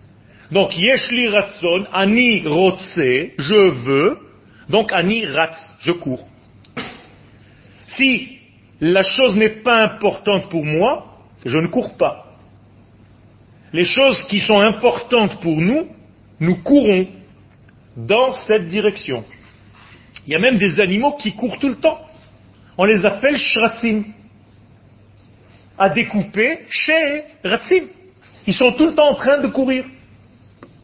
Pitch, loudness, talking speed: 195 Hz, -16 LUFS, 125 wpm